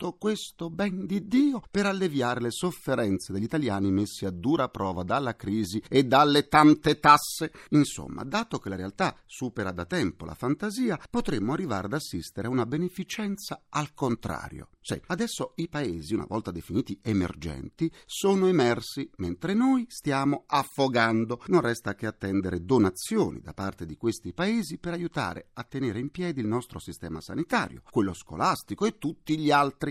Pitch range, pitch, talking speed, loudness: 100-170 Hz, 135 Hz, 160 wpm, -27 LUFS